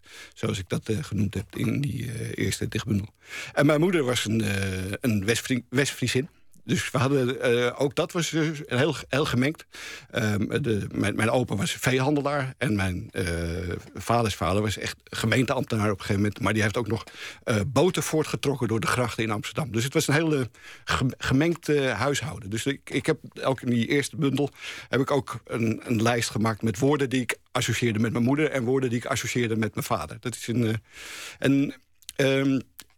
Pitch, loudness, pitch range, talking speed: 125 Hz, -26 LUFS, 110-140 Hz, 195 wpm